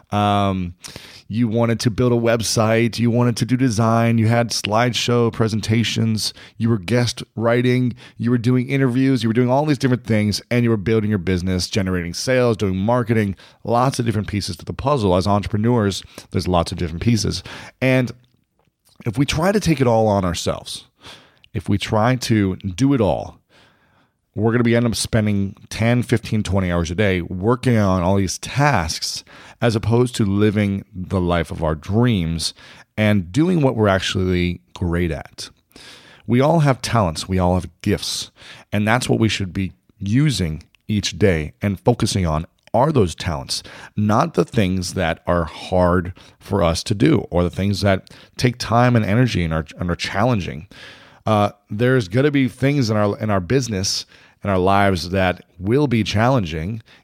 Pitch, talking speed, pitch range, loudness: 110 Hz, 180 wpm, 95-120 Hz, -19 LUFS